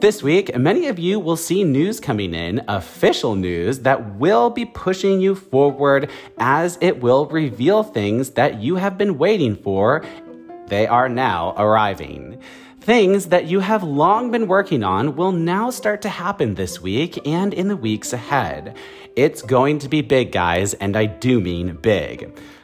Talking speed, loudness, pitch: 170 wpm, -18 LUFS, 145 Hz